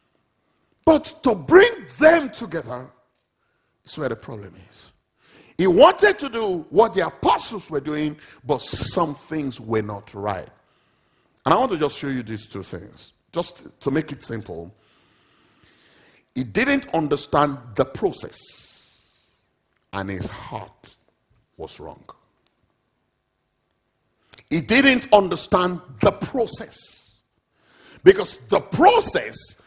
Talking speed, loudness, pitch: 115 wpm, -20 LUFS, 150 Hz